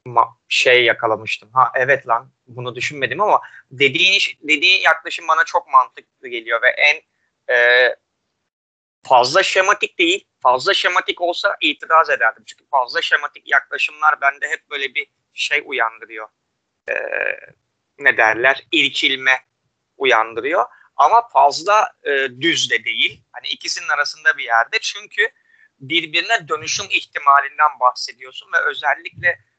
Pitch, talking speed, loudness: 170 Hz, 120 wpm, -16 LUFS